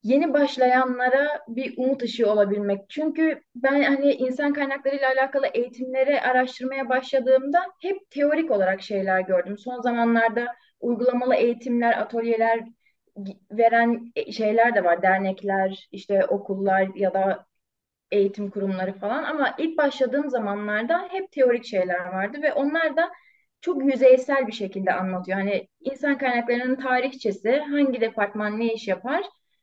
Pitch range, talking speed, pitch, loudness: 205-280 Hz, 125 wpm, 250 Hz, -23 LUFS